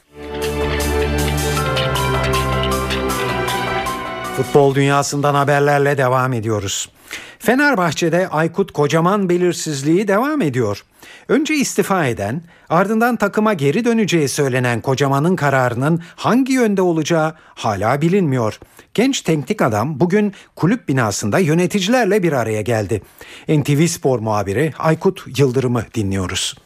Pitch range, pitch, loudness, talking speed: 115-180 Hz, 145 Hz, -17 LUFS, 95 wpm